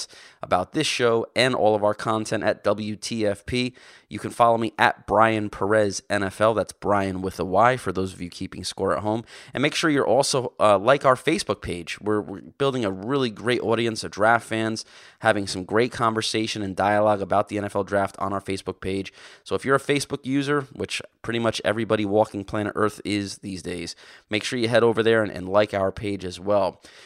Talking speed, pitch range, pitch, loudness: 210 wpm, 100-115 Hz, 105 Hz, -23 LUFS